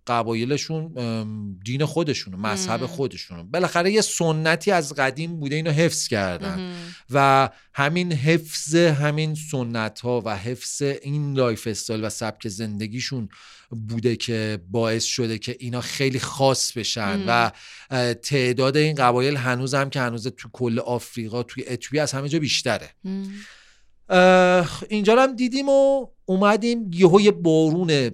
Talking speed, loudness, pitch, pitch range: 130 wpm, -22 LUFS, 135 Hz, 120-165 Hz